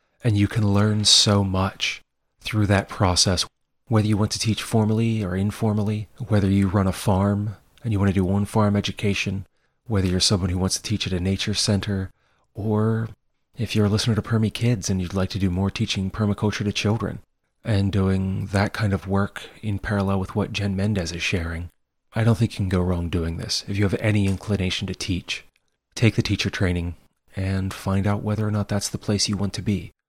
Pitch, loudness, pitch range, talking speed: 100 Hz, -23 LUFS, 95-105 Hz, 210 wpm